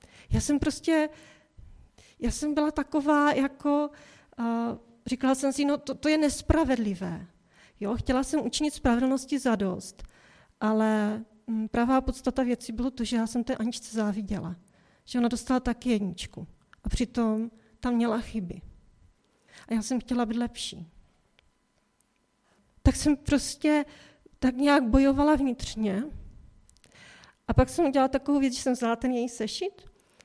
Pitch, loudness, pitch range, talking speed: 250 Hz, -28 LUFS, 225-285 Hz, 140 wpm